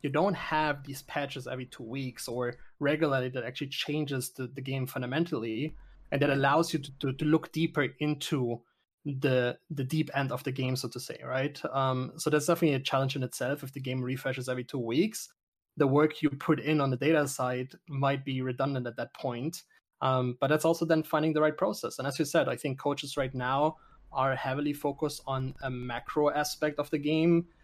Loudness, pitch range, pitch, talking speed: -31 LUFS, 130-155 Hz, 140 Hz, 210 wpm